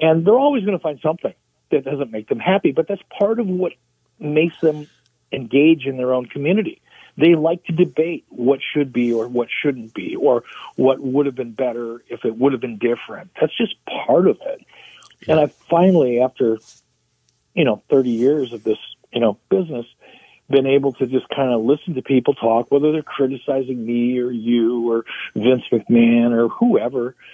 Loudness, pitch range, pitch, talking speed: -19 LUFS, 120-155 Hz, 135 Hz, 190 wpm